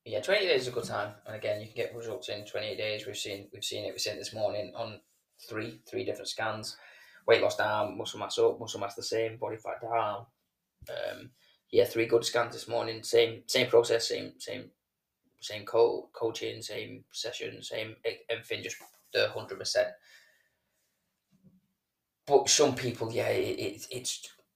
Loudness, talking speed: -31 LUFS, 180 wpm